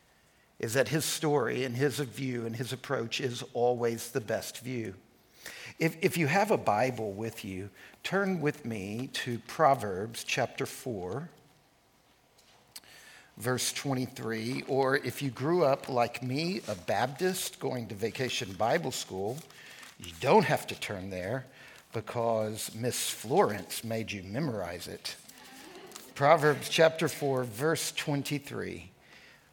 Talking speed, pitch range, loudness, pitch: 130 wpm, 115-145 Hz, -31 LUFS, 130 Hz